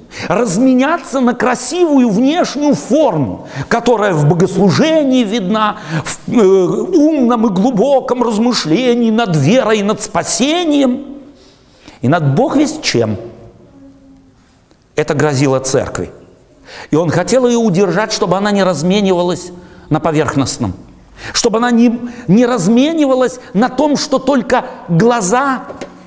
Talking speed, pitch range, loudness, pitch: 110 wpm, 175-255 Hz, -13 LUFS, 230 Hz